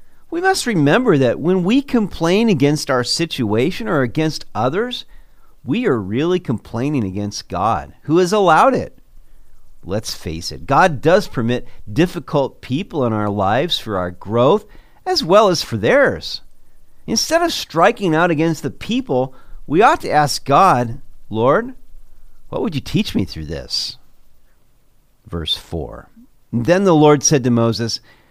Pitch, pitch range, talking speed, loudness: 140 Hz, 110-180 Hz, 150 wpm, -17 LUFS